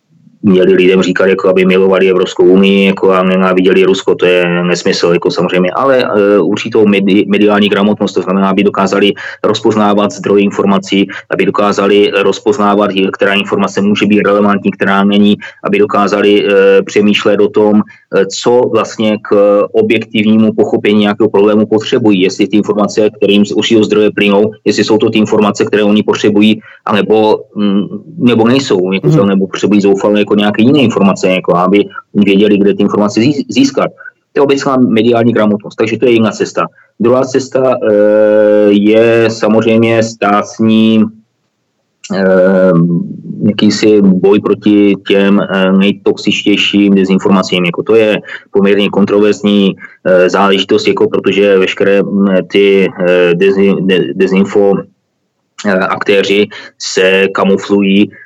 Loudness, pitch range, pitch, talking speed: -9 LUFS, 95-105 Hz, 100 Hz, 130 wpm